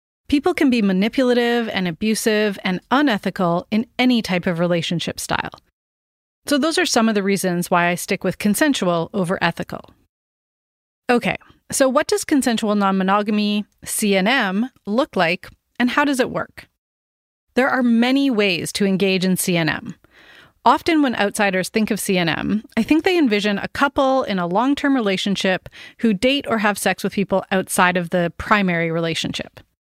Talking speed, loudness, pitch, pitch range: 160 wpm, -19 LUFS, 205 Hz, 180-245 Hz